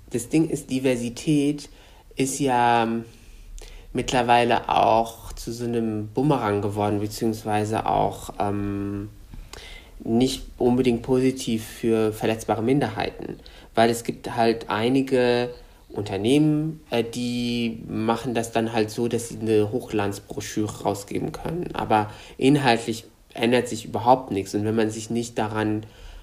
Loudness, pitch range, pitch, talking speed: -24 LUFS, 110-125 Hz, 115 Hz, 120 wpm